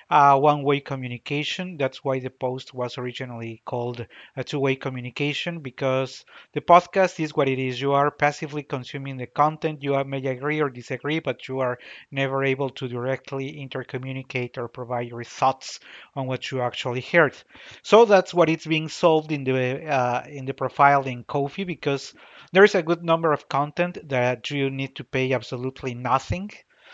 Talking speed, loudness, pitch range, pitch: 170 wpm, -24 LUFS, 130-150 Hz, 135 Hz